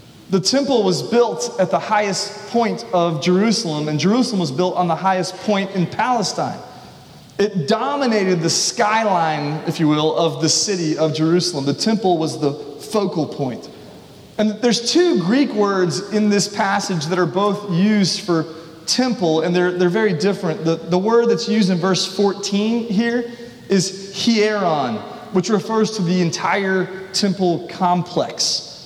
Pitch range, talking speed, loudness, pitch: 170-215 Hz, 155 wpm, -18 LUFS, 190 Hz